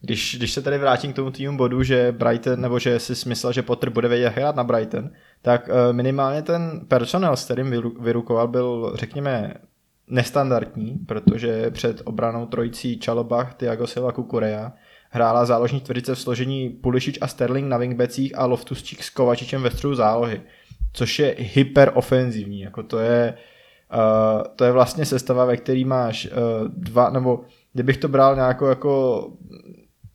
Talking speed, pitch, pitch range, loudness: 155 wpm, 125 Hz, 120-130 Hz, -21 LUFS